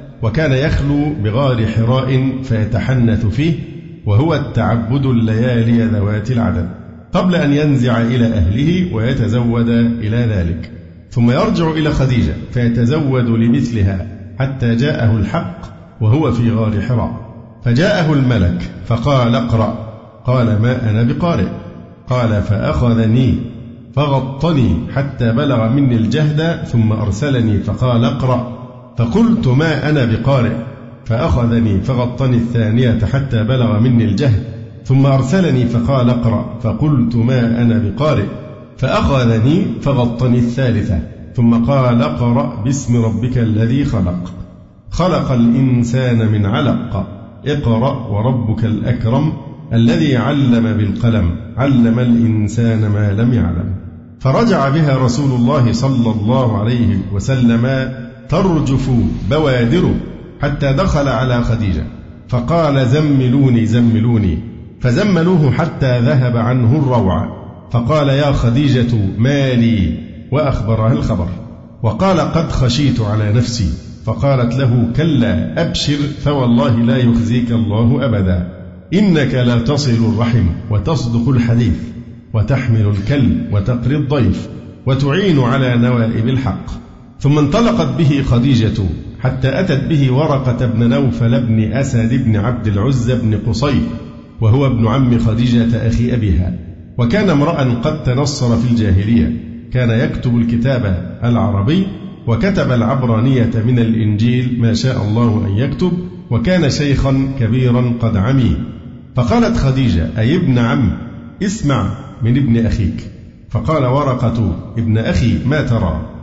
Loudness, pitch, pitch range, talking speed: -14 LUFS, 120 Hz, 115-135 Hz, 110 wpm